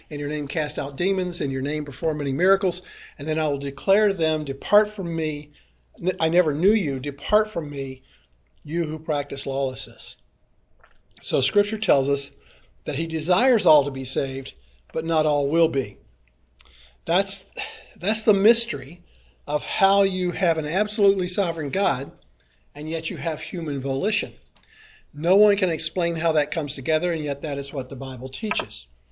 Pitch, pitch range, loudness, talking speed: 155 Hz, 140-180 Hz, -23 LUFS, 170 wpm